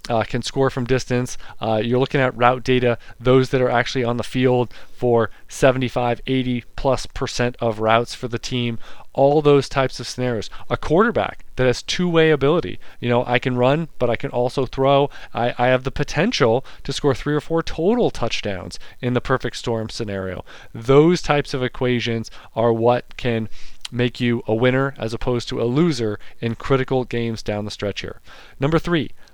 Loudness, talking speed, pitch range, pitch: -20 LUFS, 190 wpm, 115-135 Hz, 125 Hz